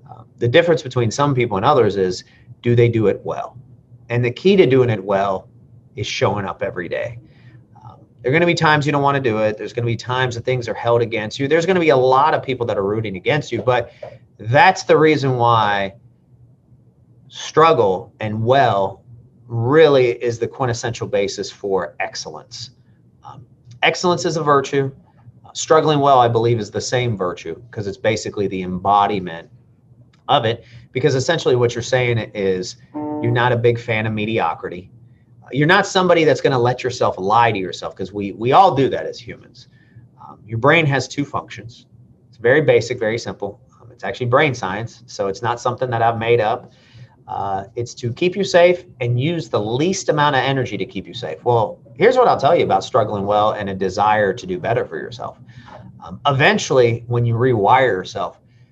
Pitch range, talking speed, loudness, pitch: 115-135 Hz, 195 wpm, -17 LUFS, 120 Hz